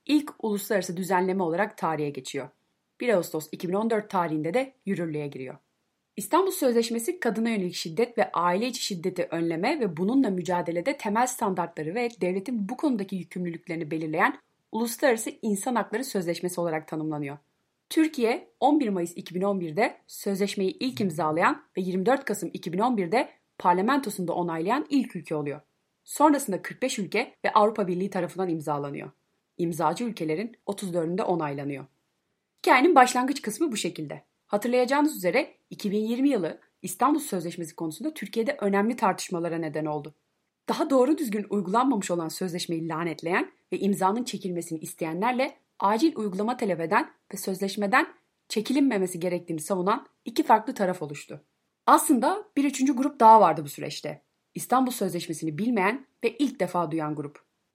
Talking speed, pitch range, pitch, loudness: 130 wpm, 170-245 Hz, 200 Hz, -26 LUFS